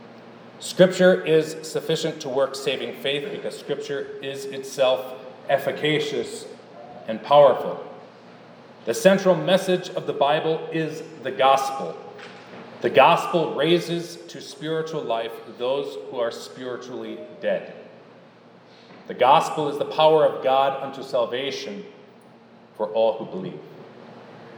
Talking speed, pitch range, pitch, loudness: 115 wpm, 135-185 Hz, 155 Hz, -22 LUFS